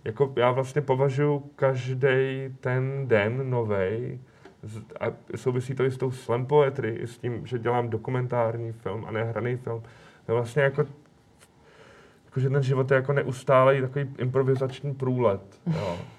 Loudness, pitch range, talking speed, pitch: -26 LUFS, 120-135 Hz, 150 wpm, 130 Hz